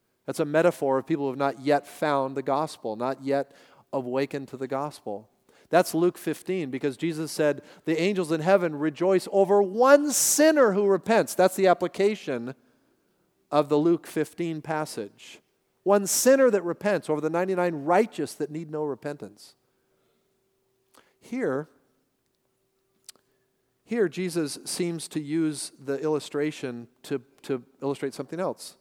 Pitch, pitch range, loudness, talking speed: 155 Hz, 140-180 Hz, -25 LUFS, 140 wpm